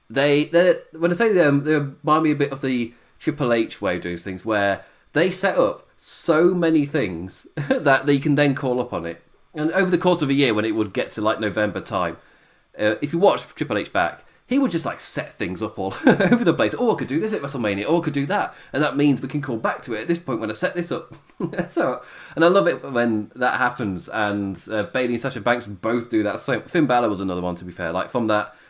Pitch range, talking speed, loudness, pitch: 105-155 Hz, 260 wpm, -22 LUFS, 135 Hz